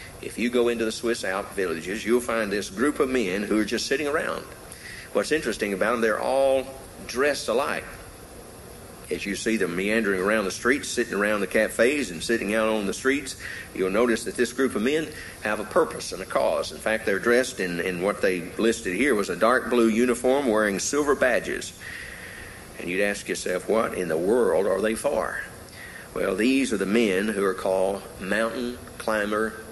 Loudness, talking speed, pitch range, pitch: -25 LUFS, 195 wpm, 105-130 Hz, 115 Hz